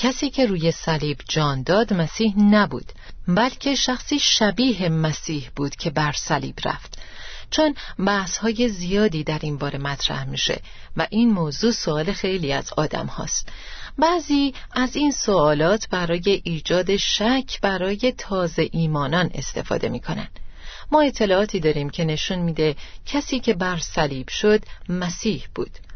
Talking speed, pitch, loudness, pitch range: 135 wpm, 190 Hz, -22 LUFS, 155-225 Hz